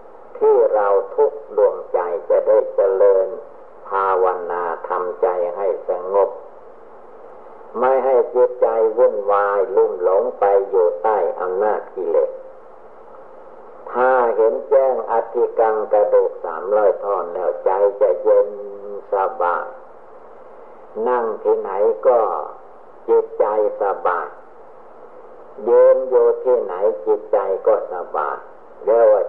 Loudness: -18 LUFS